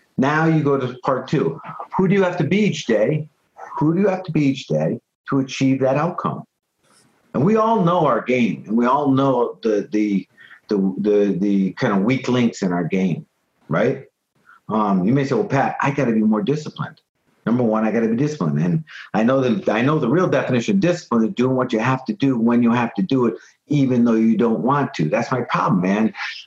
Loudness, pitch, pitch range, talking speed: -19 LUFS, 130 Hz, 110-150 Hz, 230 wpm